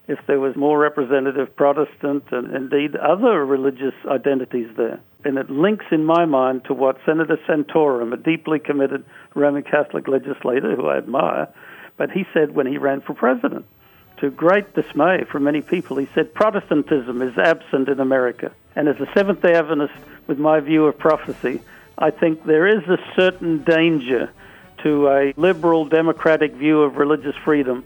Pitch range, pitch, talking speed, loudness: 135-160 Hz, 145 Hz, 165 wpm, -19 LUFS